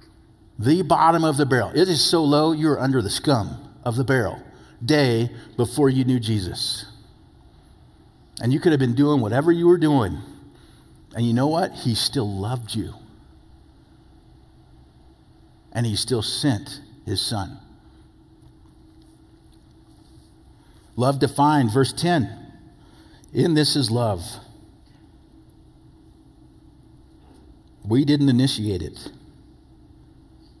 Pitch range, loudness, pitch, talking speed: 105-145 Hz, -21 LUFS, 120 Hz, 110 wpm